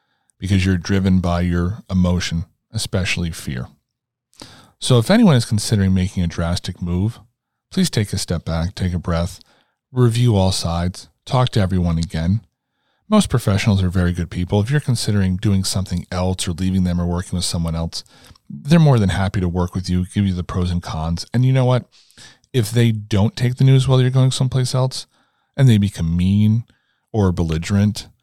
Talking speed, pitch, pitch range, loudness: 185 wpm, 95 Hz, 90-120 Hz, -19 LUFS